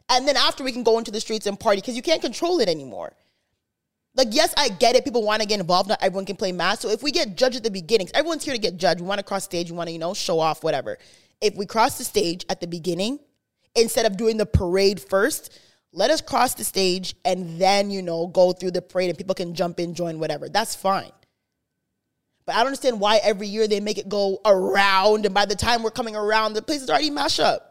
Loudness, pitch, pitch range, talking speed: -22 LUFS, 210 Hz, 190-250 Hz, 260 wpm